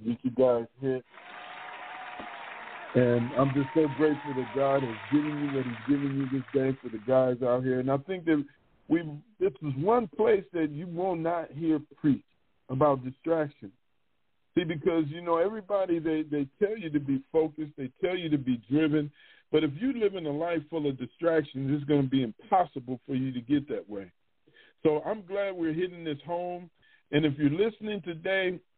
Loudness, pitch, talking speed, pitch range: -29 LUFS, 150 Hz, 195 wpm, 130-165 Hz